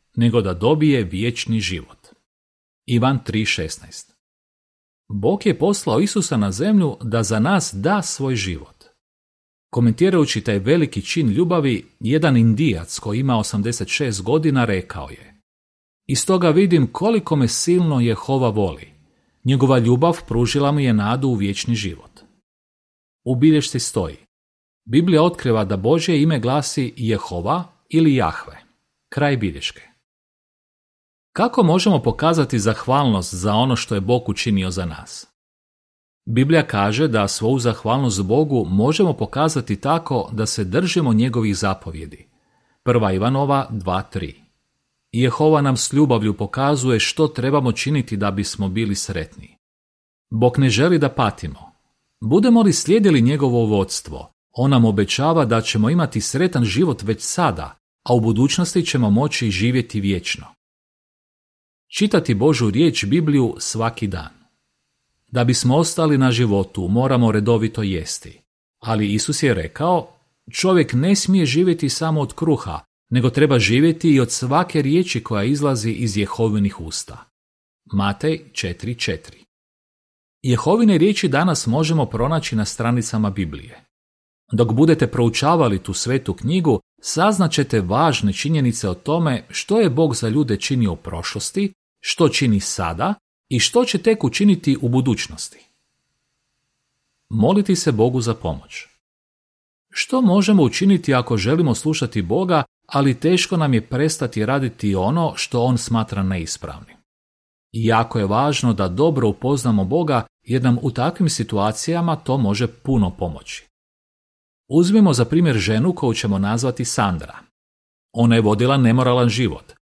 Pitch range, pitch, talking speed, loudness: 105-155 Hz, 120 Hz, 130 wpm, -18 LUFS